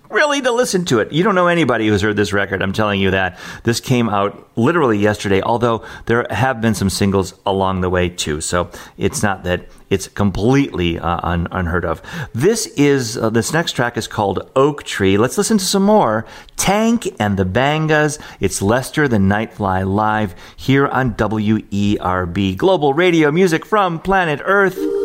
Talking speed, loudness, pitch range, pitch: 185 wpm, -16 LUFS, 95-145 Hz, 110 Hz